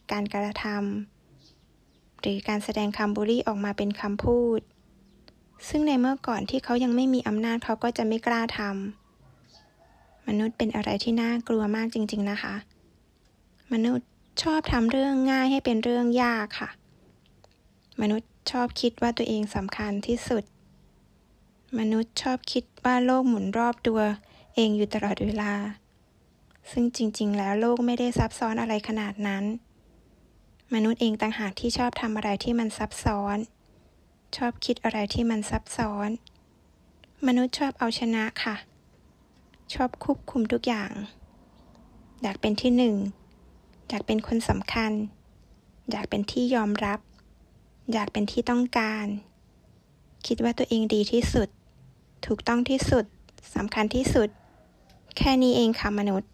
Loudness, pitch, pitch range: -27 LUFS, 225 Hz, 210-240 Hz